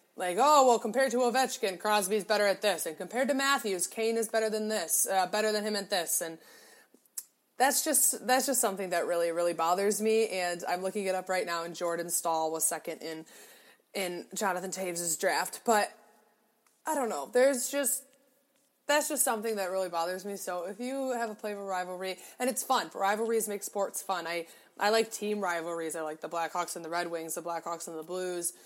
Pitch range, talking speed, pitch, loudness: 175-240 Hz, 210 wpm, 205 Hz, -30 LUFS